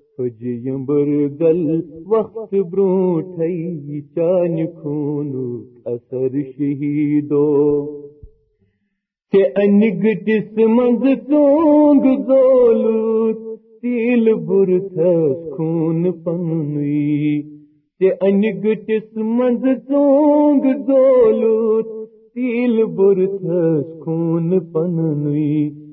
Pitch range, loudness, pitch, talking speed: 150-225 Hz, -17 LUFS, 180 Hz, 50 wpm